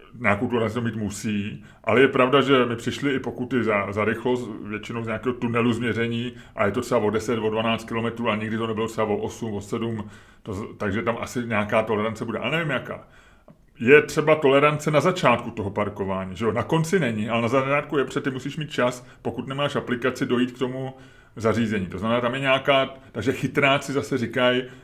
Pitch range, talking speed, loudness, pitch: 110-135 Hz, 210 wpm, -23 LUFS, 120 Hz